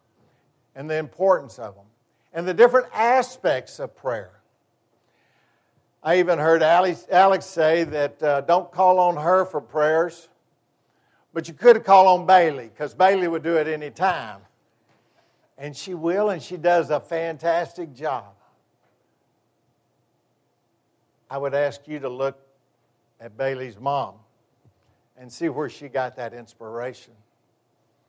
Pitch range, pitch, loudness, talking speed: 120-175 Hz, 145 Hz, -21 LUFS, 130 wpm